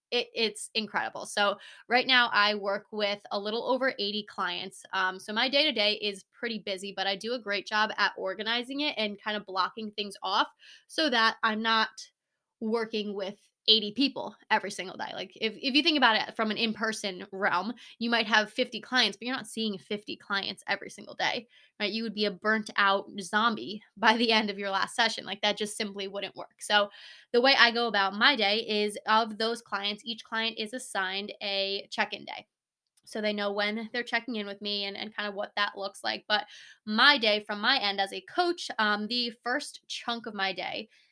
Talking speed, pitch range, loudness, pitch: 215 wpm, 200-235 Hz, -28 LUFS, 215 Hz